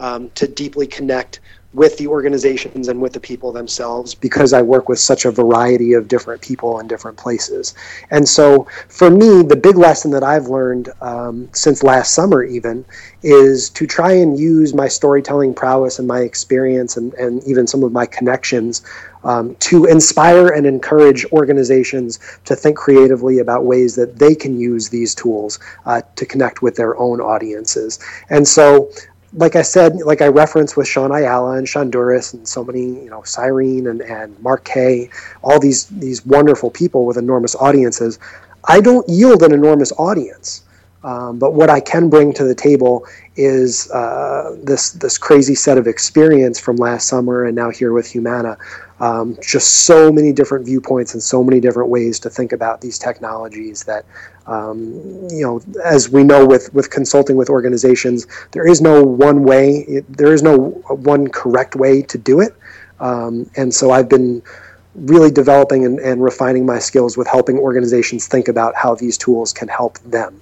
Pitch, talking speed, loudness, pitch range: 130 Hz, 180 wpm, -12 LUFS, 120-145 Hz